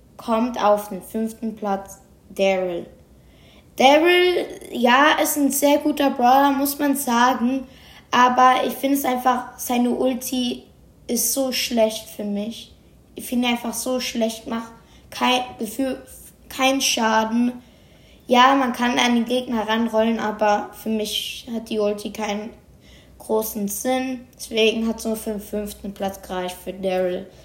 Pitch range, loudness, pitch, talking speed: 215-255 Hz, -21 LUFS, 235 Hz, 140 wpm